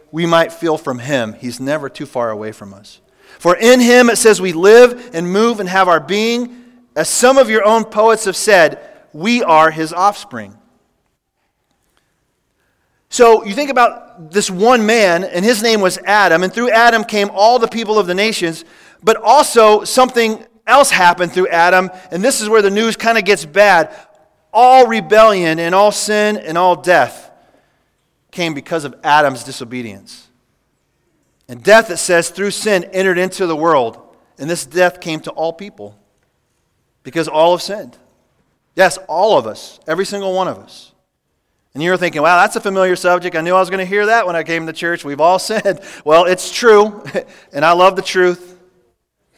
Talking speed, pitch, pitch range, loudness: 185 wpm, 185 Hz, 165-220 Hz, -13 LUFS